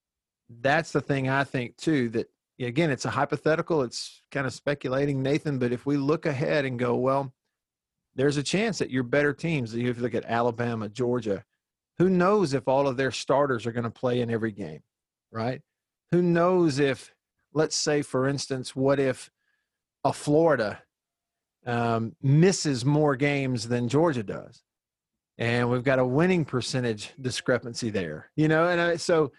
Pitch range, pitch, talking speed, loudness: 120-150 Hz, 135 Hz, 165 wpm, -26 LUFS